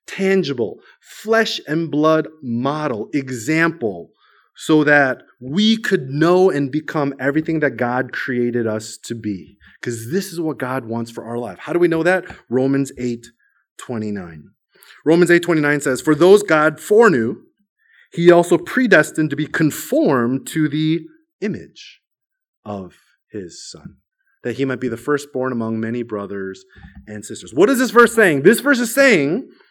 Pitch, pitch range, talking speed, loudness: 150 Hz, 120-175 Hz, 150 wpm, -17 LUFS